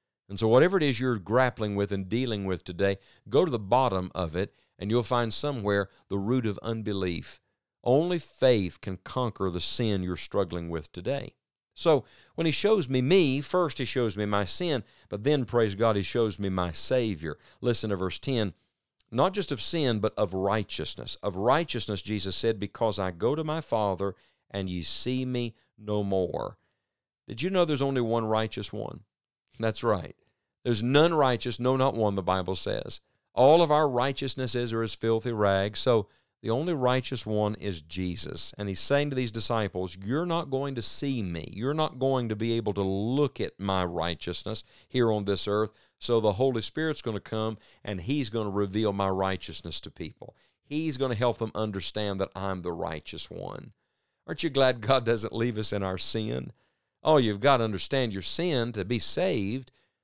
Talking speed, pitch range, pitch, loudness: 195 wpm, 100-130 Hz, 110 Hz, -28 LUFS